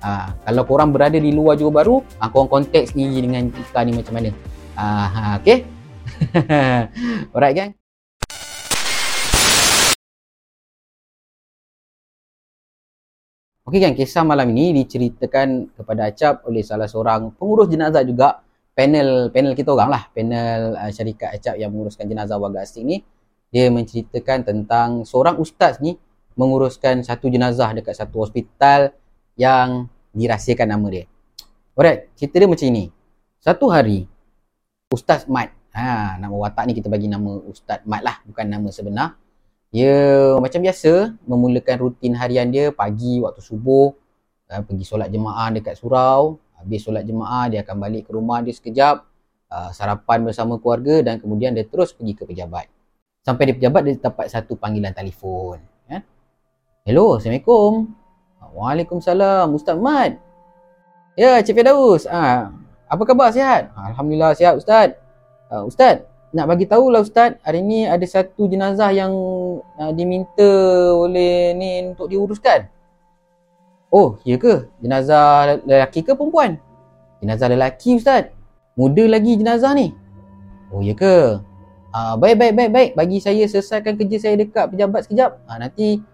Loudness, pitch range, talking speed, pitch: -16 LUFS, 110-175 Hz, 140 wpm, 130 Hz